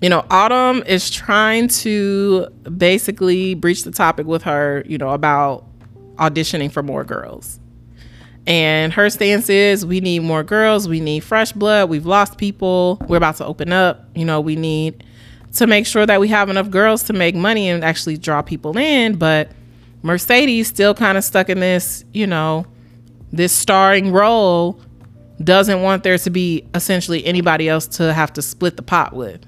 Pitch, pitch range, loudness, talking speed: 175 Hz, 155-200 Hz, -15 LUFS, 175 wpm